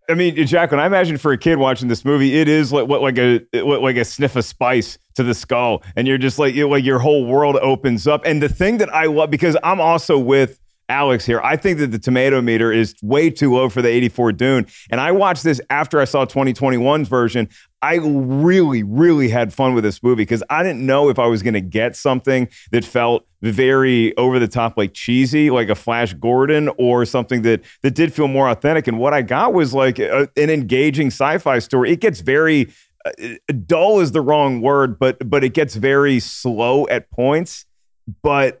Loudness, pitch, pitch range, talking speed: -16 LUFS, 135 Hz, 120-150 Hz, 215 wpm